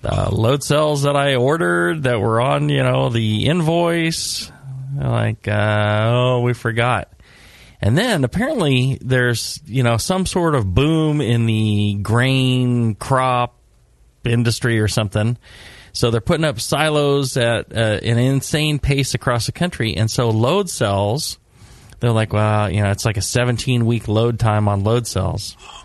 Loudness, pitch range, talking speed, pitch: -18 LUFS, 110-135 Hz, 160 wpm, 120 Hz